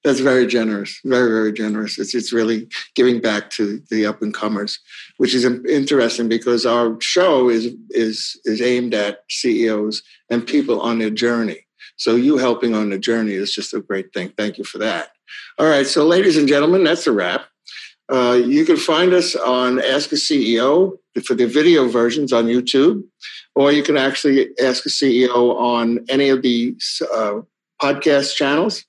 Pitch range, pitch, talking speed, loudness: 110-135 Hz, 120 Hz, 180 wpm, -17 LUFS